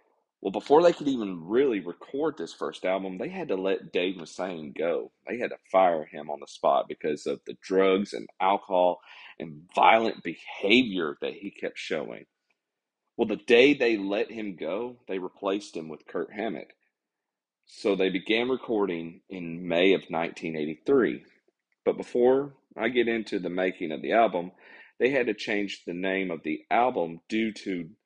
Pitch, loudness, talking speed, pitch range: 95 Hz, -27 LUFS, 170 wpm, 85-110 Hz